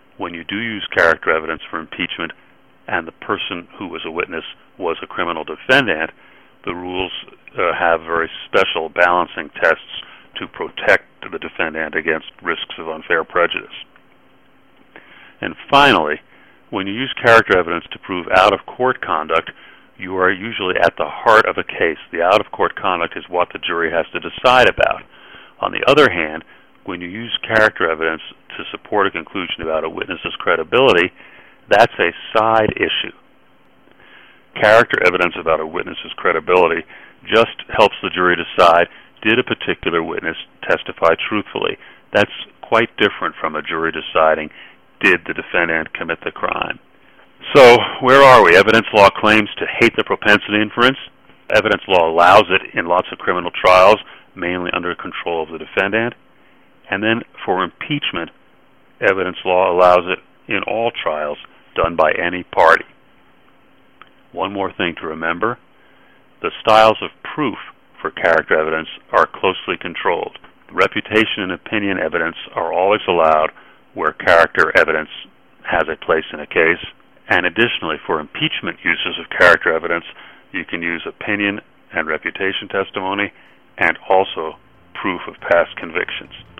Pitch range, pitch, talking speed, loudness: 85-110 Hz, 90 Hz, 150 wpm, -16 LUFS